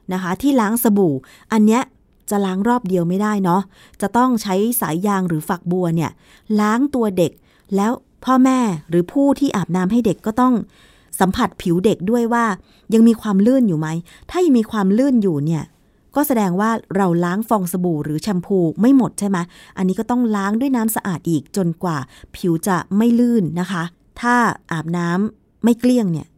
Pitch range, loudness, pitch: 175-235 Hz, -18 LUFS, 200 Hz